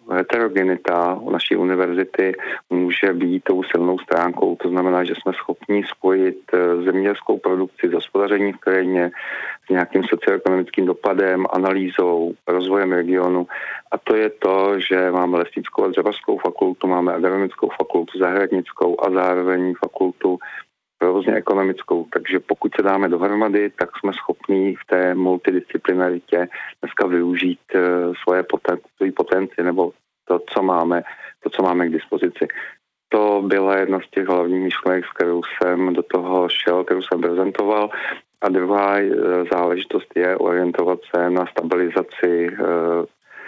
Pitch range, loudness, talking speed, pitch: 90-95 Hz, -19 LUFS, 135 wpm, 90 Hz